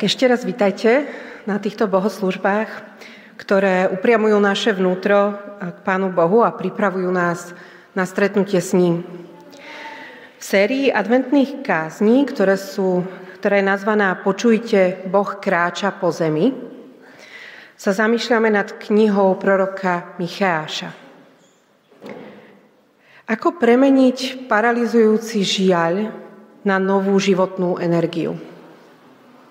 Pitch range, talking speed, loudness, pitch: 185-230 Hz, 95 wpm, -18 LUFS, 200 Hz